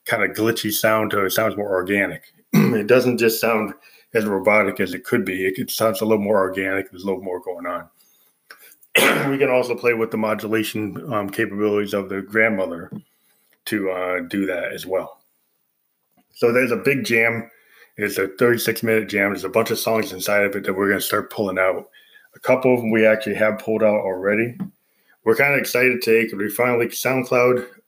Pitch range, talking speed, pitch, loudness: 100-120 Hz, 200 wpm, 110 Hz, -20 LUFS